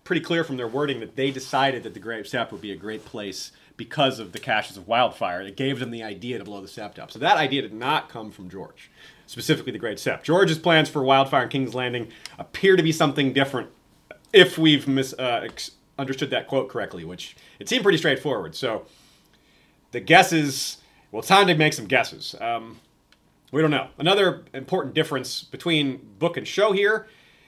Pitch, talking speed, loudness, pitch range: 135 Hz, 205 wpm, -22 LUFS, 125-160 Hz